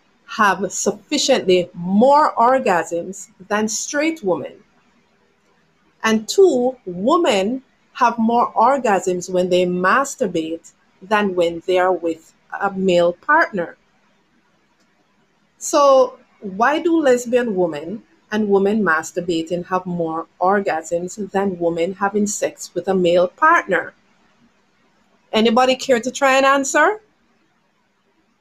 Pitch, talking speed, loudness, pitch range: 200 Hz, 105 wpm, -18 LUFS, 180-255 Hz